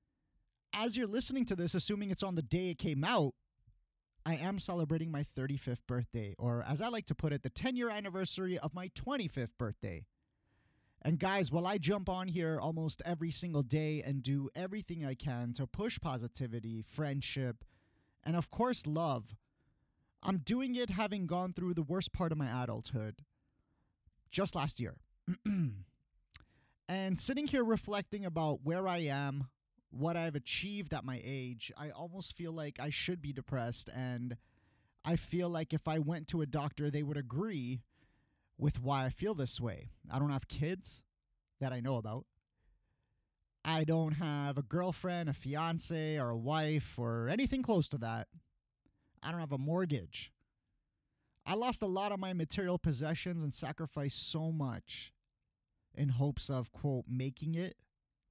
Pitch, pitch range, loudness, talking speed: 155 Hz, 130-180 Hz, -38 LUFS, 165 wpm